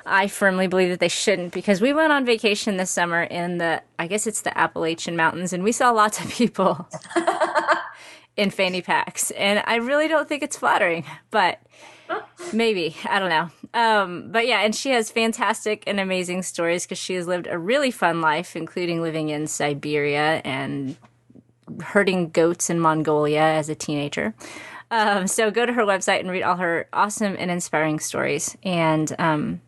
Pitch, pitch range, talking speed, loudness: 185 Hz, 165-220 Hz, 180 wpm, -22 LUFS